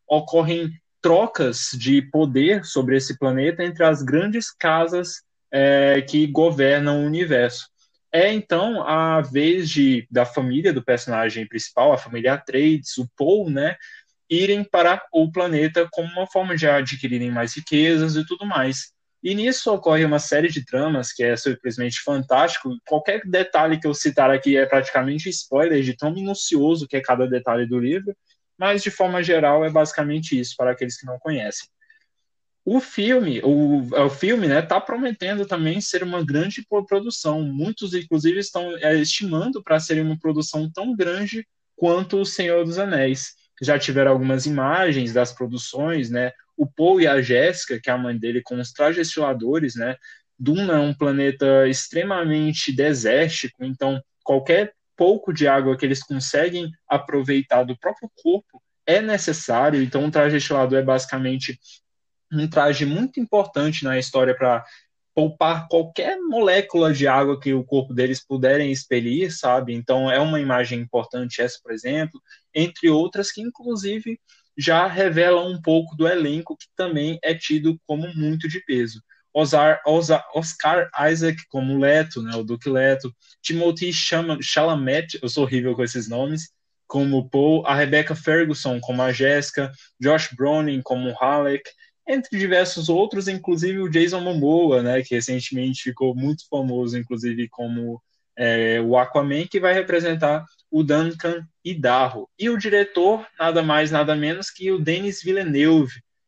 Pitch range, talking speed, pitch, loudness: 130-170 Hz, 155 wpm, 150 Hz, -21 LUFS